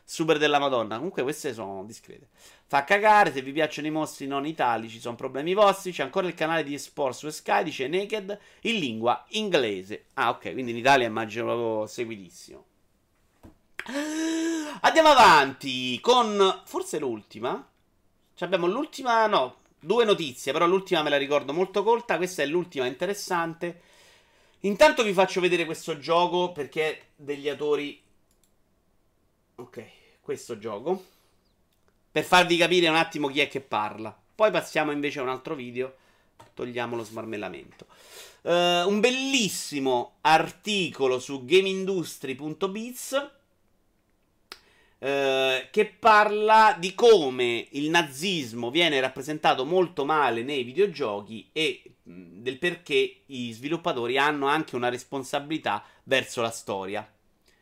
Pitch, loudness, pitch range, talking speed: 160 Hz, -25 LUFS, 130-200 Hz, 130 wpm